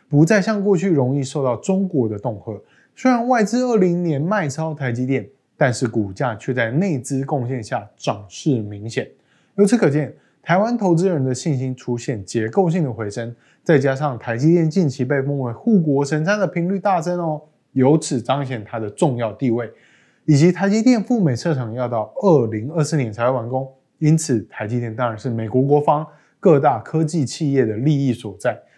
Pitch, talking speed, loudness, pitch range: 140 Hz, 280 characters per minute, -19 LUFS, 125-165 Hz